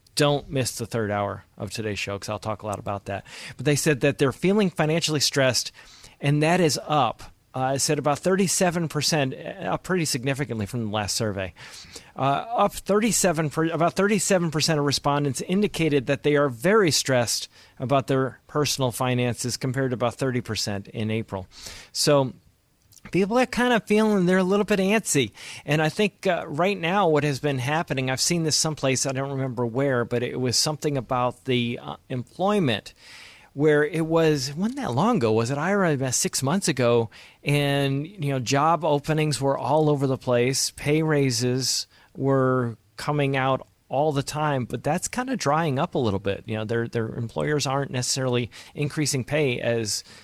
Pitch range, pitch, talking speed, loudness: 120-155 Hz, 140 Hz, 180 wpm, -24 LUFS